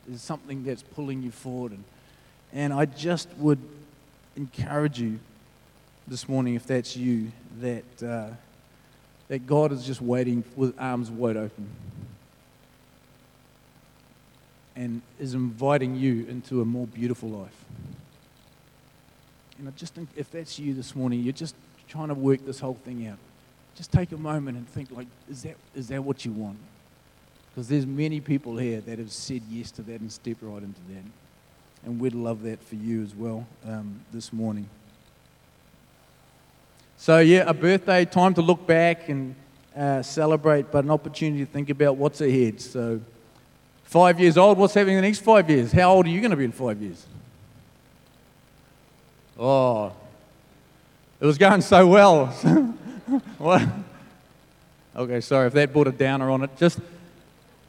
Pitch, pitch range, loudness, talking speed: 130 Hz, 120-150 Hz, -23 LUFS, 160 wpm